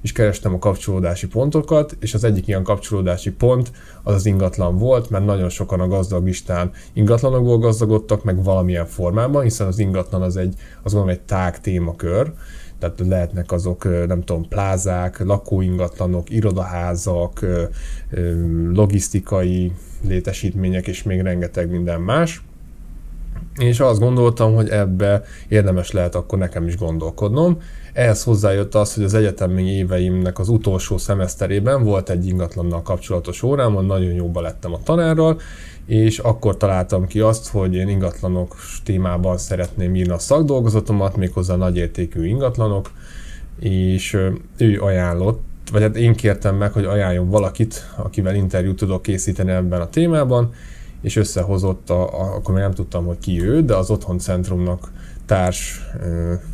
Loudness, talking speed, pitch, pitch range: -19 LUFS, 135 wpm, 95 Hz, 90-105 Hz